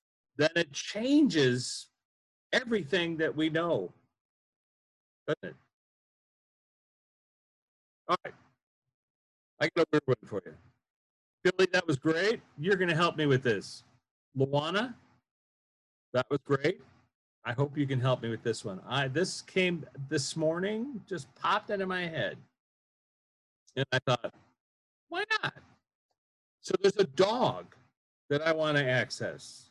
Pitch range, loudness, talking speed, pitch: 135-185 Hz, -30 LUFS, 130 wpm, 155 Hz